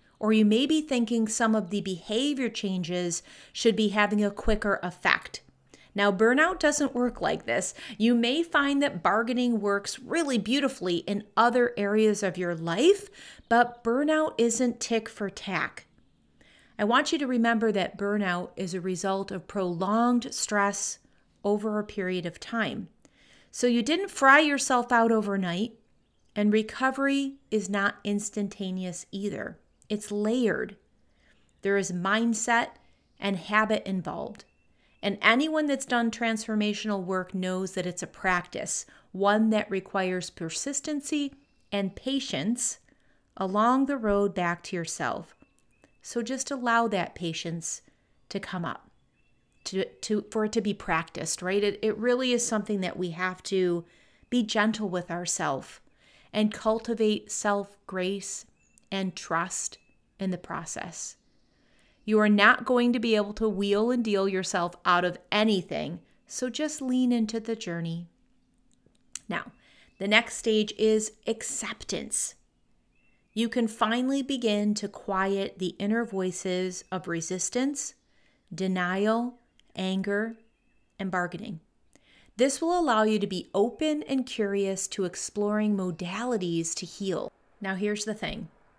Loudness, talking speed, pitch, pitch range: -27 LUFS, 135 wpm, 210 Hz, 190-235 Hz